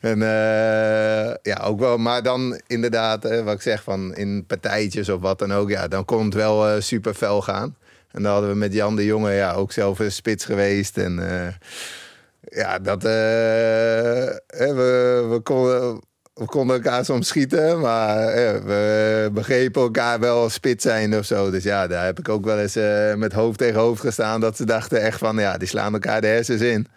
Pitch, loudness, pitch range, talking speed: 110 Hz, -21 LUFS, 105-115 Hz, 205 wpm